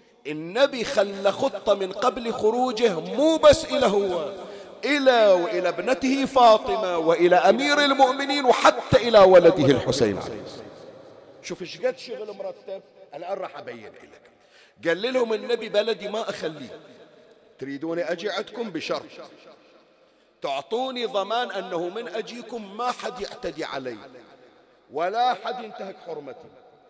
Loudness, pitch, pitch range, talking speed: -22 LUFS, 225 Hz, 190-260 Hz, 115 wpm